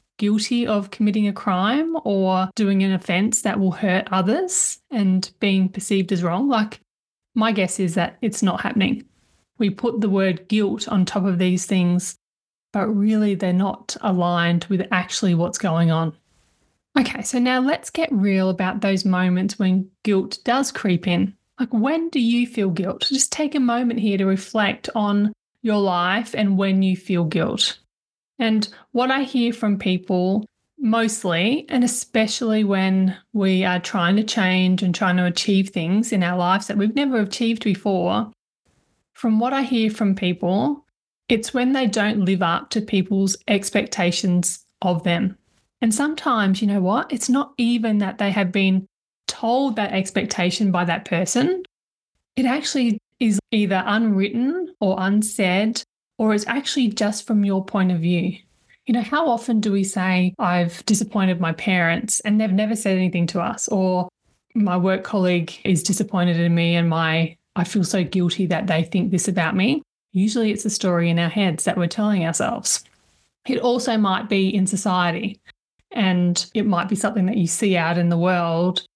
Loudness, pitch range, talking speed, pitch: -21 LUFS, 185-225 Hz, 170 wpm, 200 Hz